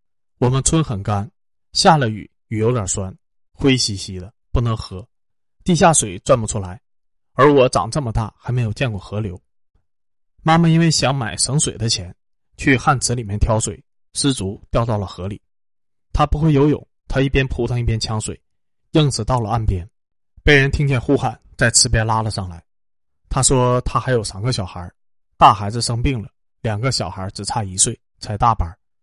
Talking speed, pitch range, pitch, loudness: 250 characters per minute, 100-130 Hz, 115 Hz, -18 LUFS